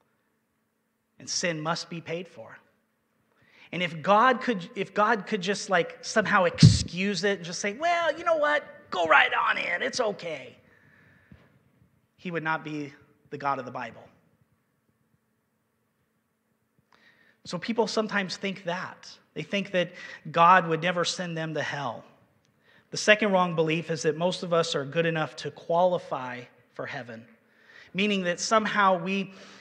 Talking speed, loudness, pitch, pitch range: 150 wpm, -26 LUFS, 180 Hz, 160-205 Hz